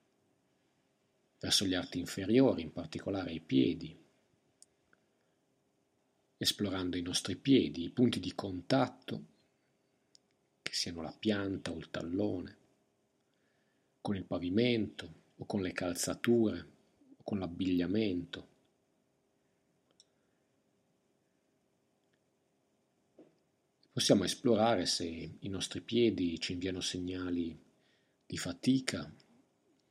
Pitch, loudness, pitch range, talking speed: 95 Hz, -34 LUFS, 90-110 Hz, 90 wpm